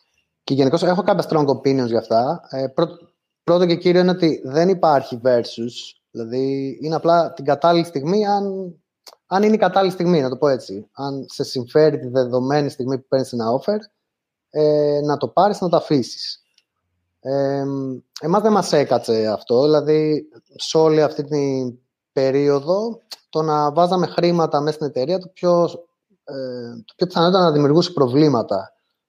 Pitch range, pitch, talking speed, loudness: 135-175 Hz, 150 Hz, 165 wpm, -19 LUFS